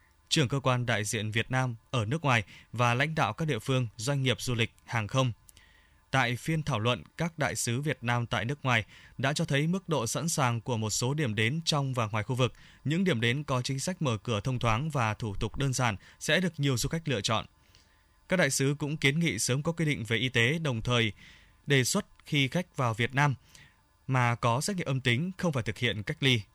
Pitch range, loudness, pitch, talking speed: 115-145 Hz, -29 LUFS, 125 Hz, 240 wpm